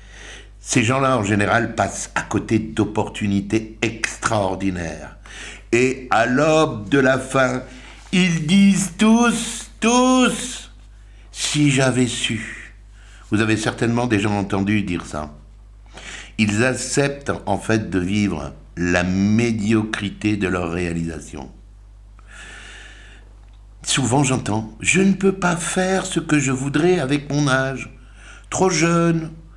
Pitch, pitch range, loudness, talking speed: 110 Hz, 100-145 Hz, -19 LUFS, 115 wpm